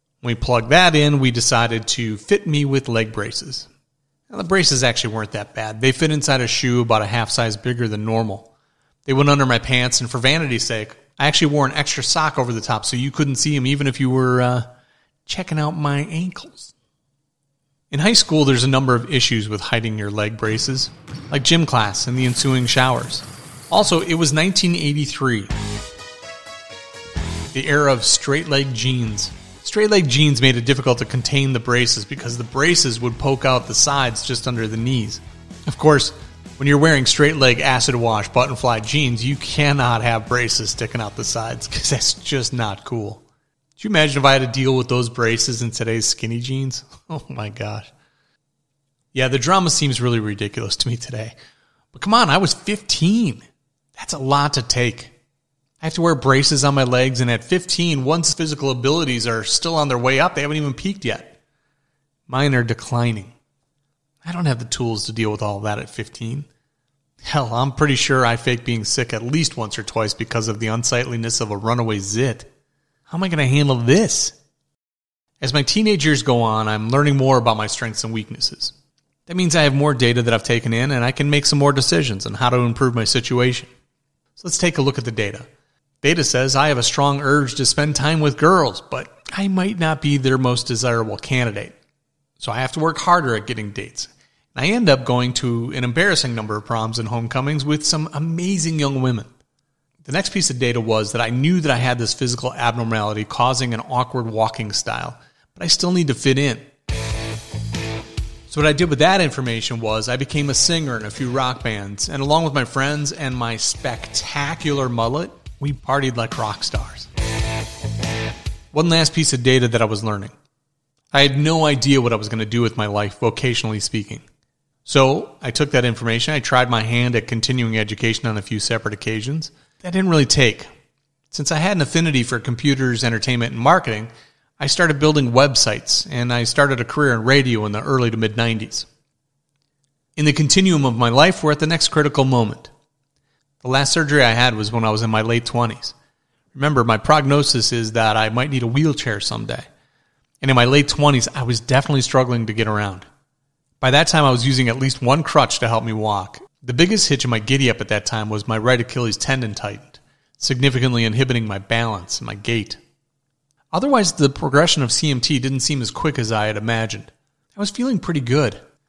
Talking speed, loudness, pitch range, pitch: 205 wpm, -18 LUFS, 115-145 Hz, 130 Hz